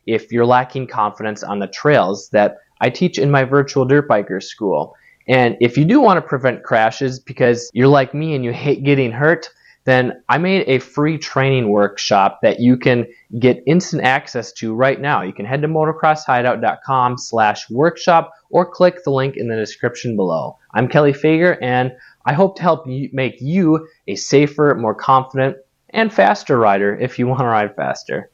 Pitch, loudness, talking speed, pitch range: 130 Hz, -16 LUFS, 180 wpm, 120-150 Hz